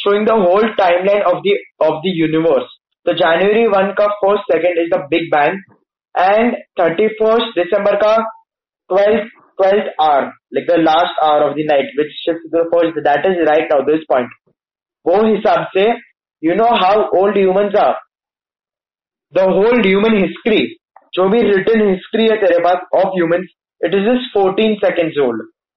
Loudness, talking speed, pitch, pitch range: -14 LUFS, 155 wpm, 195 Hz, 170-215 Hz